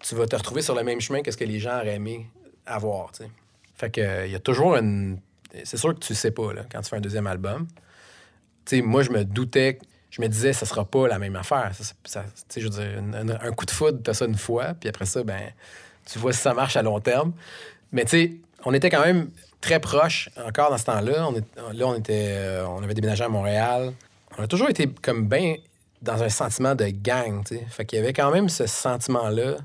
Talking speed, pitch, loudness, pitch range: 245 wpm, 115 Hz, -24 LUFS, 105-125 Hz